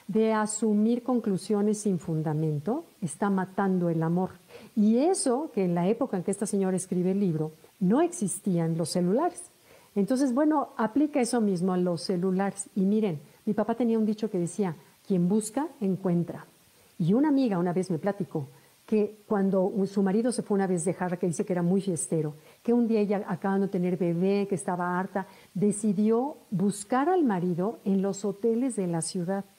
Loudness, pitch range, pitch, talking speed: -28 LUFS, 180-220 Hz, 195 Hz, 180 wpm